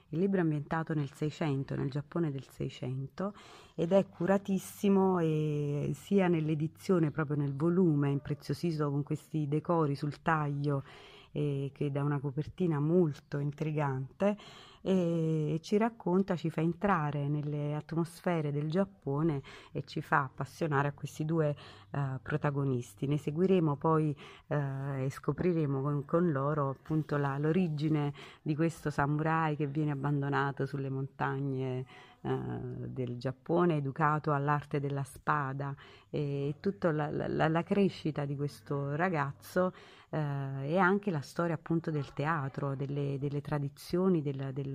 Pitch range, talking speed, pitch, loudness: 140-165 Hz, 135 wpm, 150 Hz, -33 LUFS